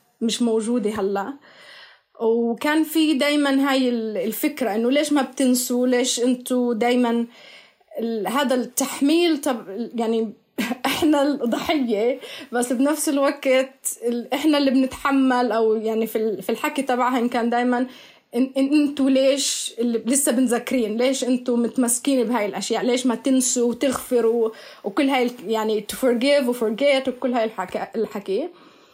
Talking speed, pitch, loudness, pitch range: 115 wpm, 250 Hz, -21 LUFS, 230-275 Hz